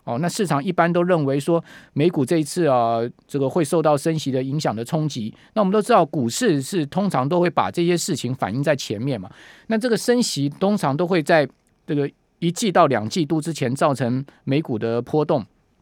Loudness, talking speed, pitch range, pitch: -21 LUFS, 305 characters per minute, 135-175 Hz, 155 Hz